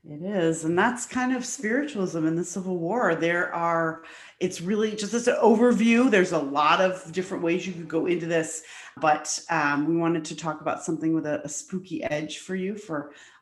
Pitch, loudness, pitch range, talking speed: 170 Hz, -25 LUFS, 160-195 Hz, 205 wpm